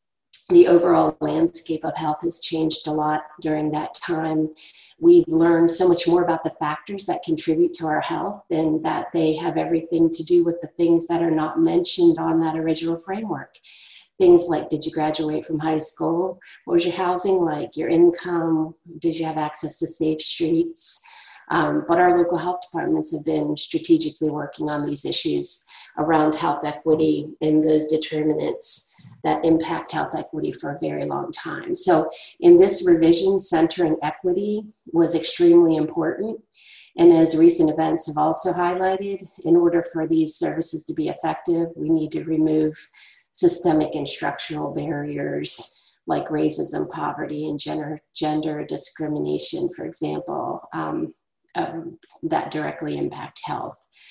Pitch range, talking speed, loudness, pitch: 155-210 Hz, 155 wpm, -21 LUFS, 165 Hz